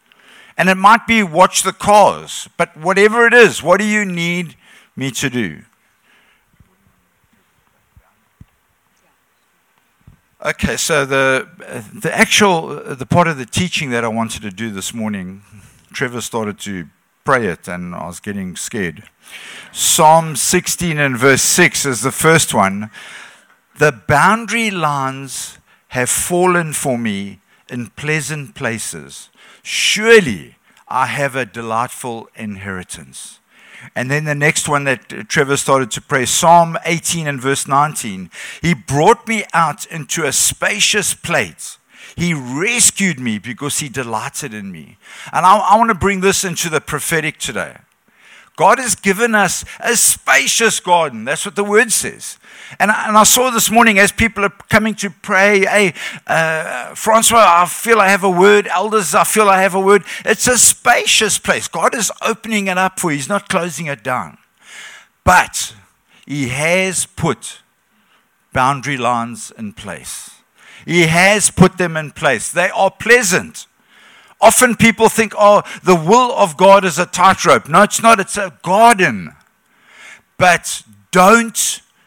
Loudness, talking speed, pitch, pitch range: -13 LUFS, 150 wpm, 170 Hz, 135-205 Hz